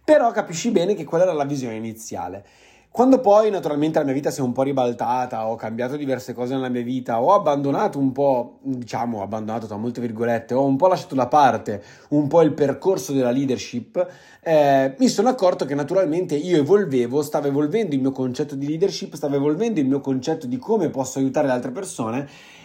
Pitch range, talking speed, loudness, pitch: 125-180 Hz, 200 wpm, -21 LUFS, 140 Hz